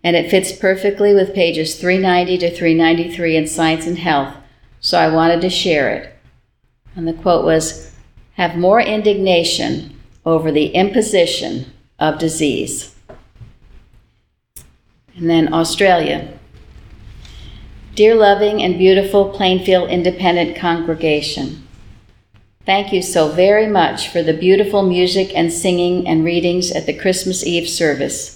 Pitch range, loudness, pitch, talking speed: 160-190 Hz, -15 LUFS, 170 Hz, 125 wpm